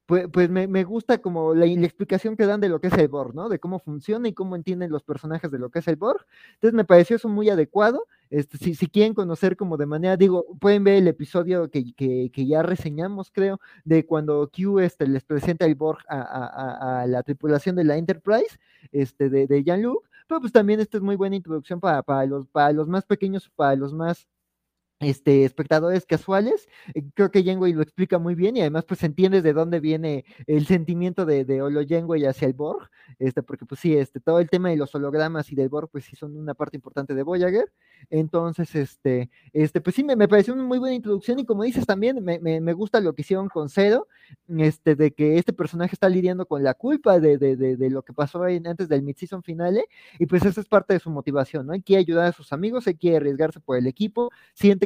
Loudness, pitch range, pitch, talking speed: -22 LUFS, 150-195 Hz, 170 Hz, 230 wpm